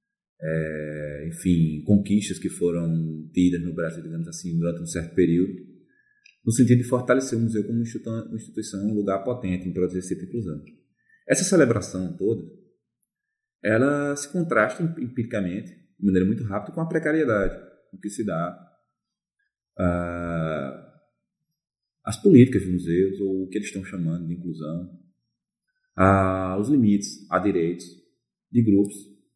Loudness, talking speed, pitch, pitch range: -24 LUFS, 135 wpm, 100 Hz, 85-125 Hz